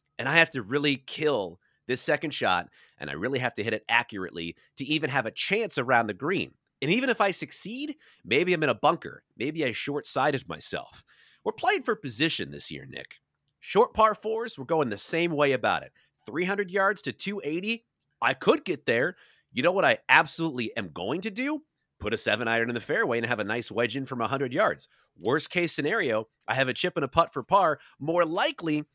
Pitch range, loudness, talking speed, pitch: 120-195 Hz, -27 LUFS, 215 wpm, 150 Hz